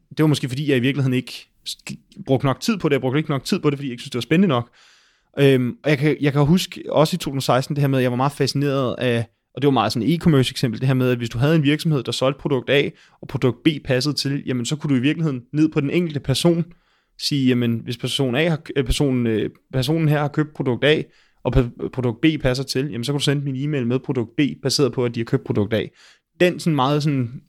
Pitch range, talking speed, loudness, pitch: 130-150 Hz, 275 wpm, -20 LUFS, 140 Hz